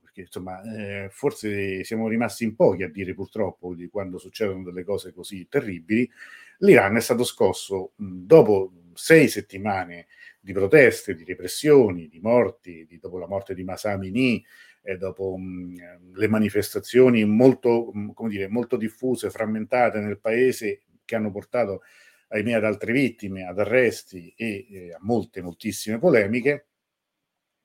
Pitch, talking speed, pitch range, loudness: 105 Hz, 145 wpm, 95-115 Hz, -23 LUFS